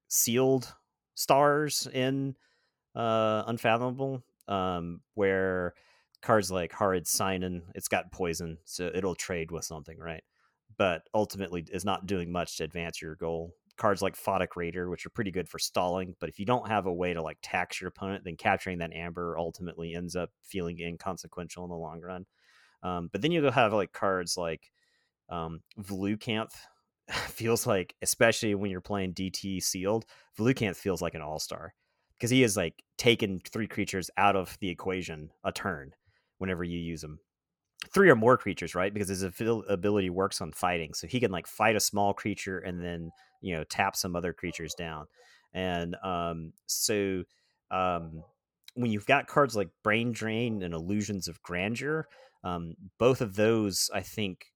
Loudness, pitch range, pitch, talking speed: -30 LUFS, 85-105 Hz, 95 Hz, 170 wpm